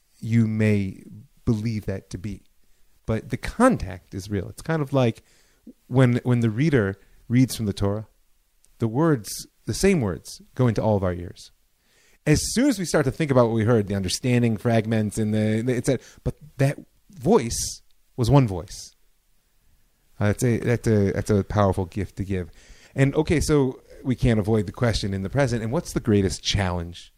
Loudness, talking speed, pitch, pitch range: -23 LUFS, 185 wpm, 110 Hz, 100-130 Hz